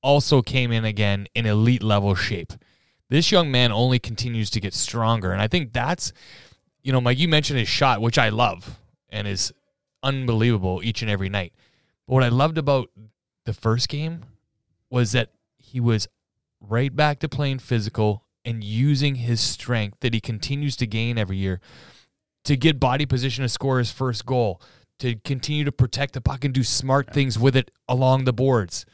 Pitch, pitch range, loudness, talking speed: 120 Hz, 110-135 Hz, -22 LUFS, 185 wpm